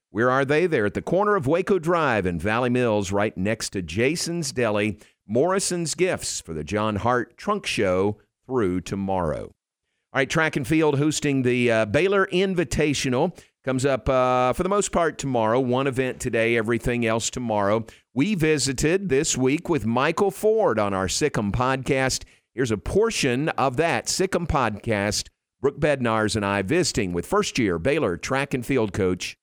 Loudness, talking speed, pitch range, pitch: -23 LUFS, 165 wpm, 105-155 Hz, 125 Hz